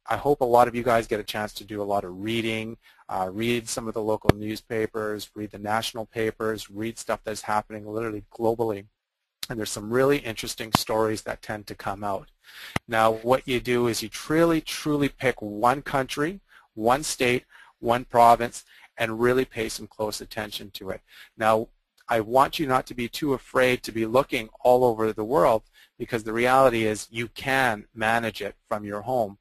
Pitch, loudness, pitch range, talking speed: 115 Hz, -25 LUFS, 110-125 Hz, 195 wpm